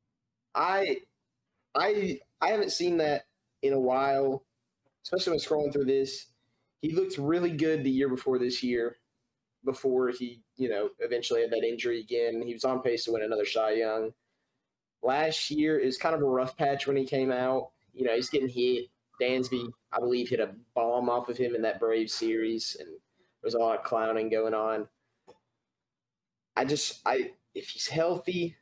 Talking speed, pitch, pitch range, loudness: 180 wpm, 130 Hz, 120-155 Hz, -30 LUFS